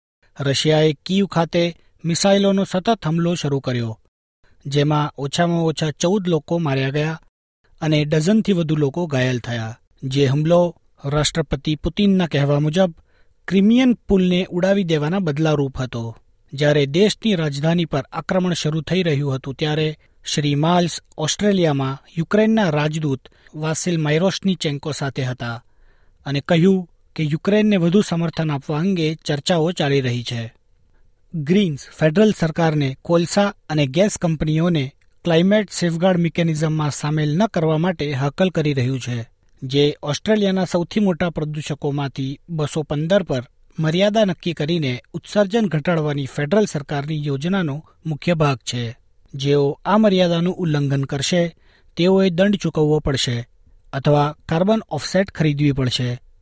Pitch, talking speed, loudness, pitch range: 155 Hz, 125 wpm, -19 LUFS, 140-180 Hz